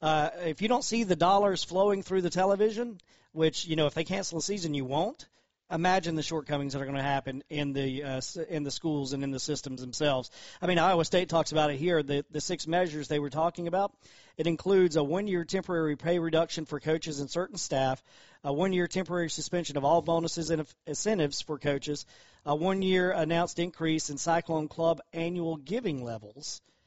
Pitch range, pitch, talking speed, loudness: 145-180 Hz, 165 Hz, 200 wpm, -30 LUFS